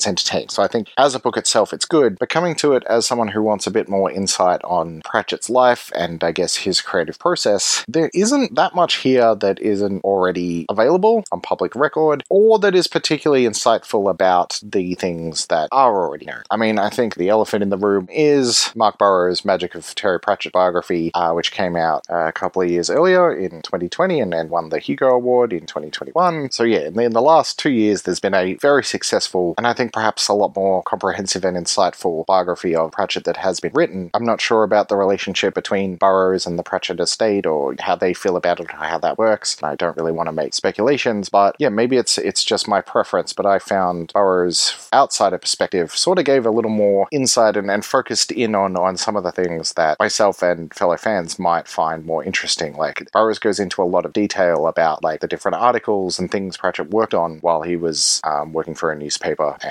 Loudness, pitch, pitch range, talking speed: -18 LUFS, 100 Hz, 90-120 Hz, 220 wpm